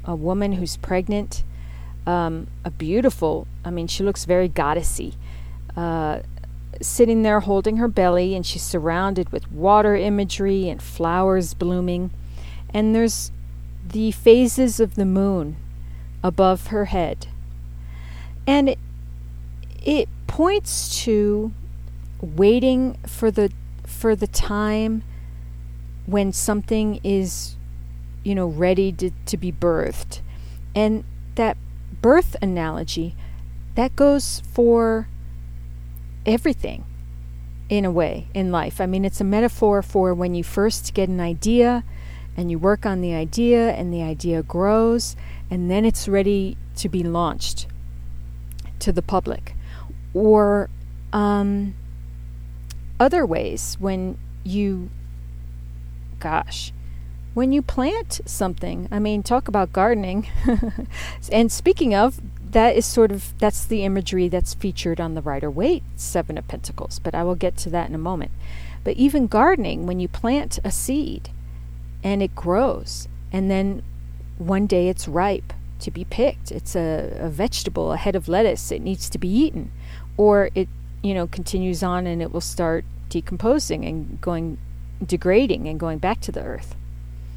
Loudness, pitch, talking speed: -21 LUFS, 170 Hz, 135 wpm